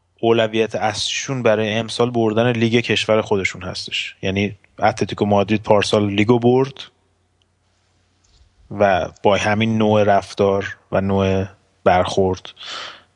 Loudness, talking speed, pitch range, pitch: -18 LUFS, 105 wpm, 95-110 Hz, 105 Hz